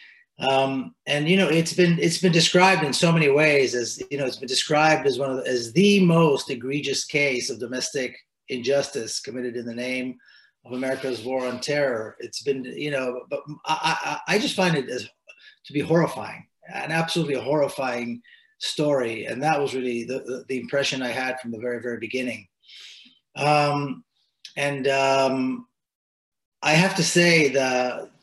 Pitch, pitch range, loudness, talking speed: 140 Hz, 125-160 Hz, -23 LUFS, 170 wpm